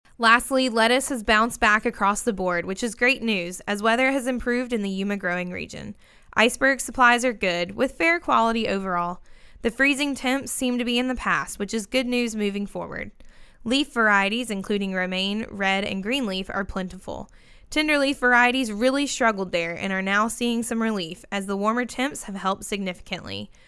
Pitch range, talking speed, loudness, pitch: 195-250 Hz, 180 wpm, -23 LUFS, 225 Hz